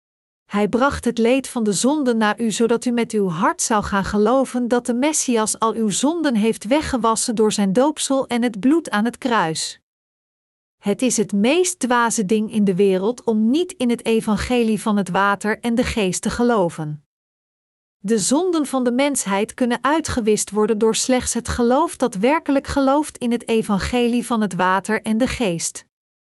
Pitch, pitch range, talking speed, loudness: 230 Hz, 210-255 Hz, 180 wpm, -19 LUFS